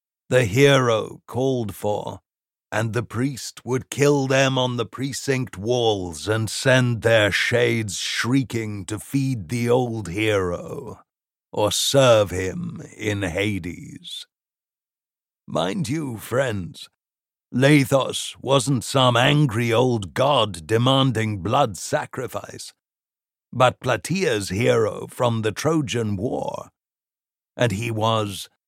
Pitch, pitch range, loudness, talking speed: 120 Hz, 110-135 Hz, -21 LUFS, 105 wpm